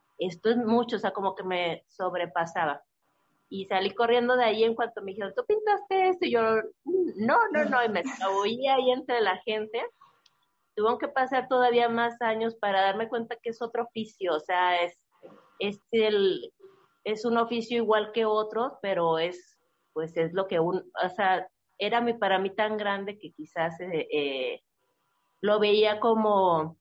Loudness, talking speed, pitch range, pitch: -27 LUFS, 175 wpm, 190-240 Hz, 215 Hz